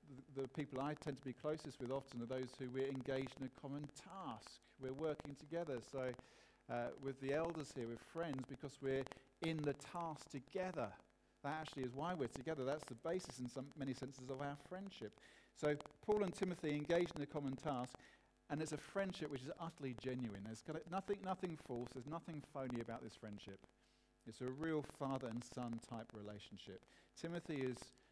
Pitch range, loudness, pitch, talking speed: 130-155 Hz, -47 LUFS, 140 Hz, 190 wpm